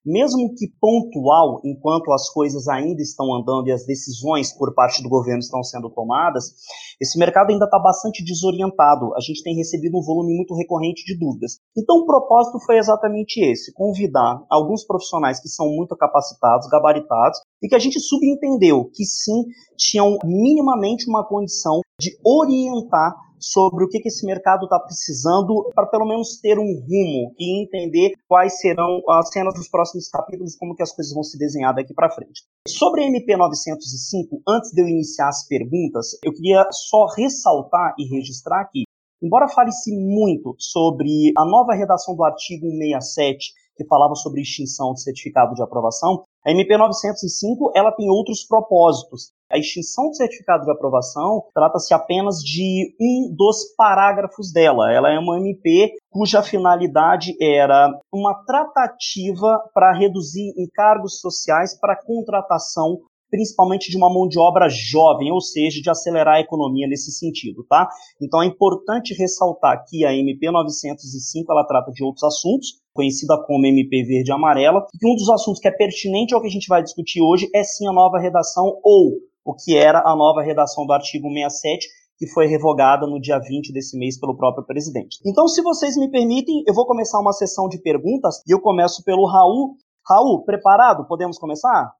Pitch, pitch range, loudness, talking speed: 180 Hz, 150-210 Hz, -18 LUFS, 170 wpm